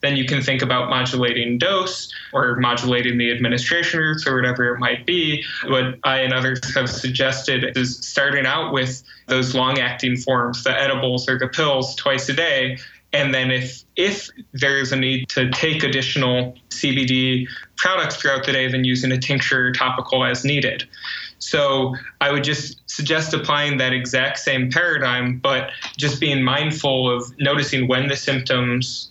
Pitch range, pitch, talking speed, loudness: 125-140 Hz, 130 Hz, 170 wpm, -19 LUFS